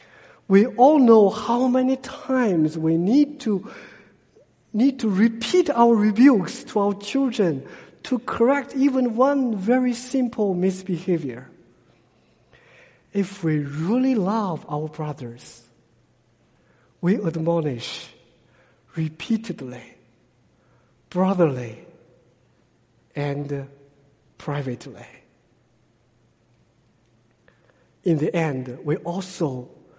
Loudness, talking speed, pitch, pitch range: -22 LUFS, 80 wpm, 180 Hz, 140-235 Hz